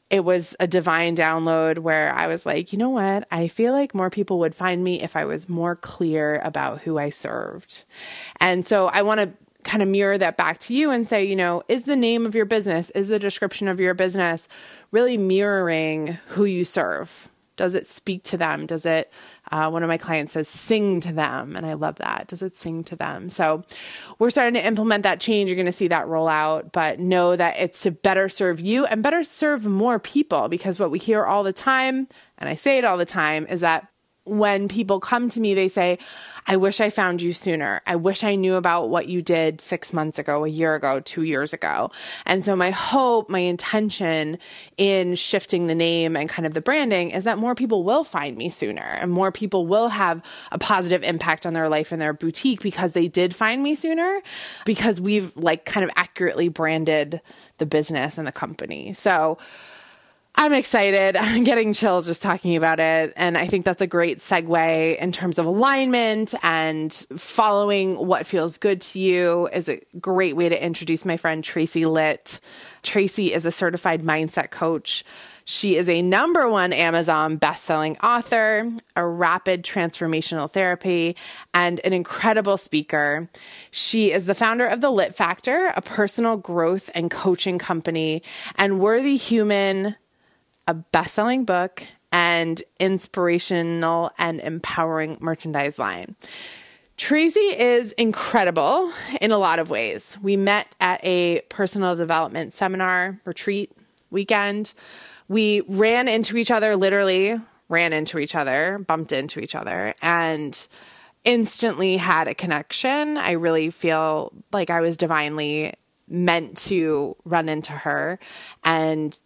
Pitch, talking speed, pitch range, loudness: 180 Hz, 175 wpm, 165-210 Hz, -21 LUFS